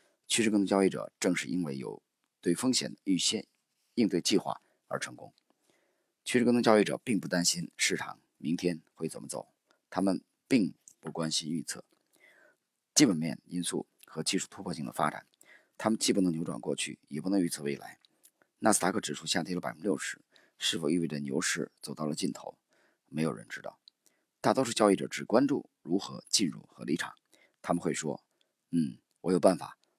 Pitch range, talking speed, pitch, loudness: 80-105 Hz, 275 characters per minute, 90 Hz, -31 LUFS